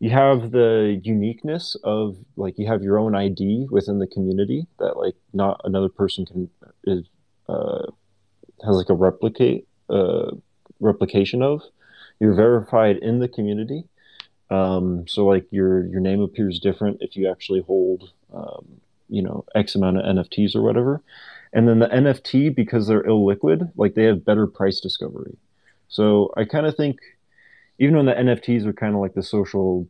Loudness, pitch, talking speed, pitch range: -21 LUFS, 105 Hz, 165 wpm, 95-120 Hz